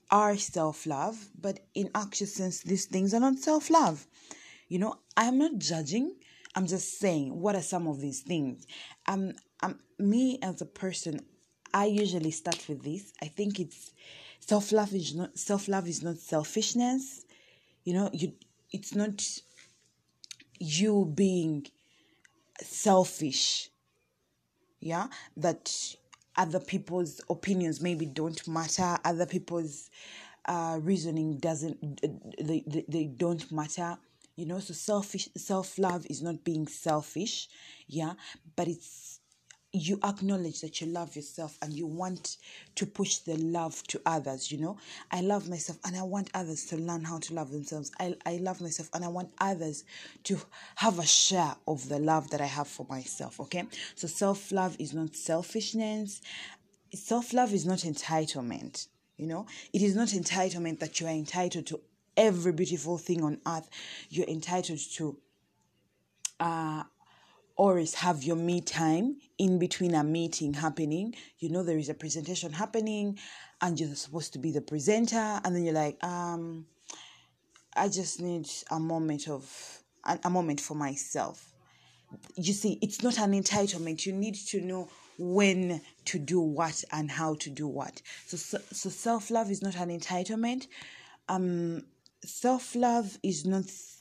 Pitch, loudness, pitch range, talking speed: 175 Hz, -32 LUFS, 160-195 Hz, 155 wpm